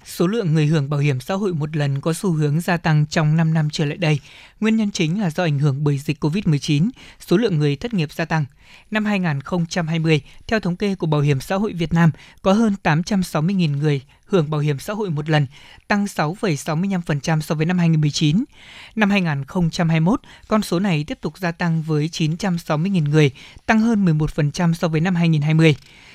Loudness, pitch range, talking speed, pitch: -20 LUFS, 150-190 Hz, 195 wpm, 165 Hz